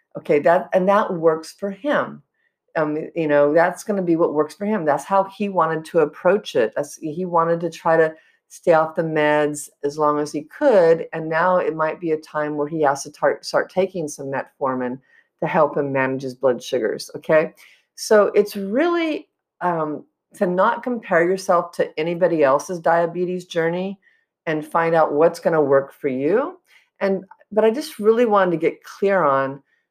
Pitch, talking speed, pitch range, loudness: 170 Hz, 195 wpm, 150-200 Hz, -20 LUFS